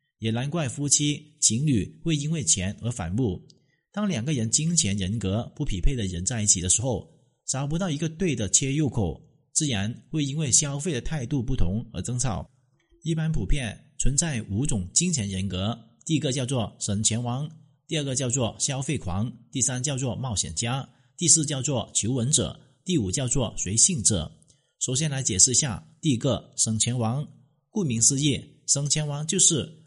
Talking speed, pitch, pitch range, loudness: 260 characters per minute, 130 Hz, 110-150 Hz, -25 LUFS